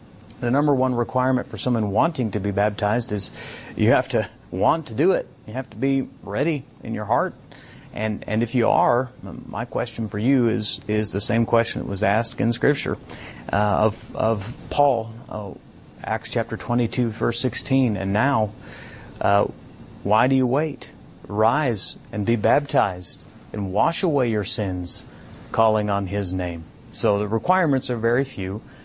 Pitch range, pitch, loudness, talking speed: 105-130 Hz, 115 Hz, -23 LUFS, 170 wpm